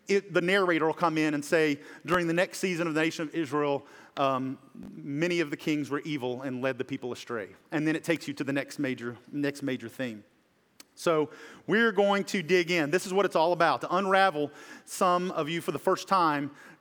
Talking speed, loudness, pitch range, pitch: 220 wpm, -28 LUFS, 140-180 Hz, 155 Hz